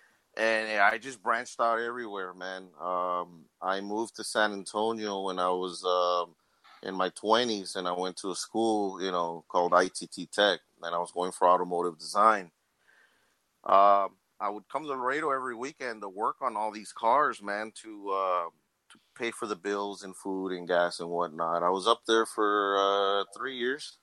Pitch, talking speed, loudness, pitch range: 95 Hz, 185 wpm, -29 LUFS, 90-105 Hz